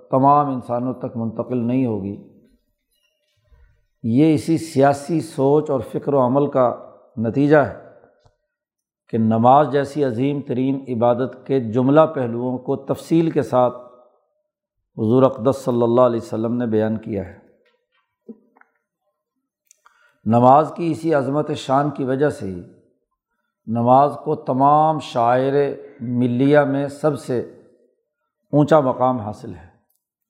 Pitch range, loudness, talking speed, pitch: 120-150 Hz, -19 LUFS, 120 wpm, 135 Hz